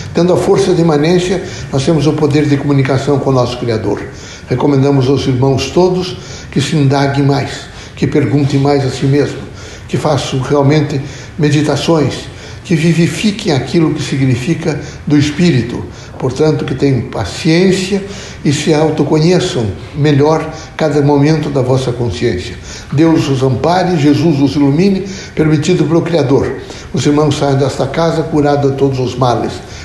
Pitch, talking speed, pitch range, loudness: 145 Hz, 145 wpm, 135-160 Hz, -12 LUFS